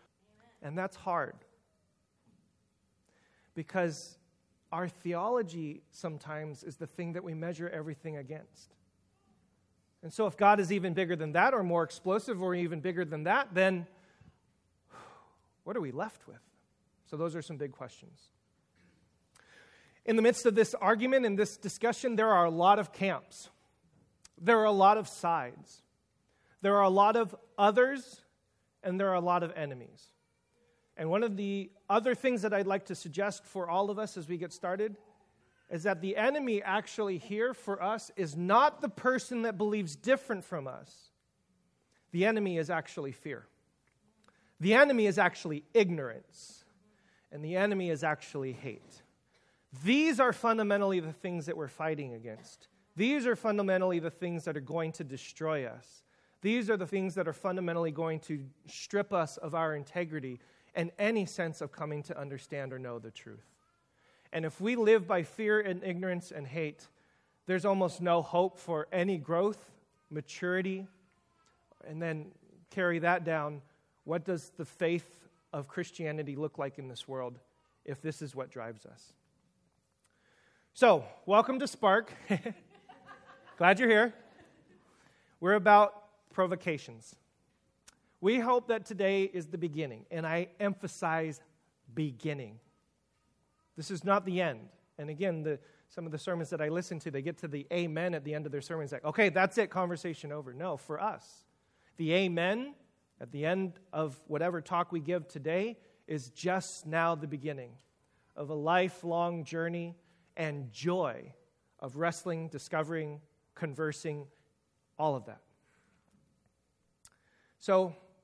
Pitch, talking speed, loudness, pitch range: 175 Hz, 155 wpm, -32 LUFS, 155-200 Hz